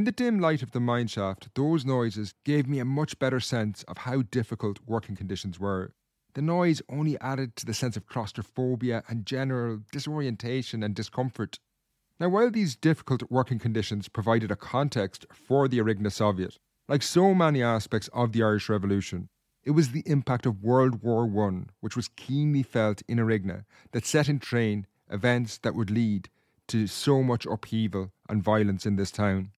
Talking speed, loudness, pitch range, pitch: 180 wpm, -28 LUFS, 105-135 Hz, 115 Hz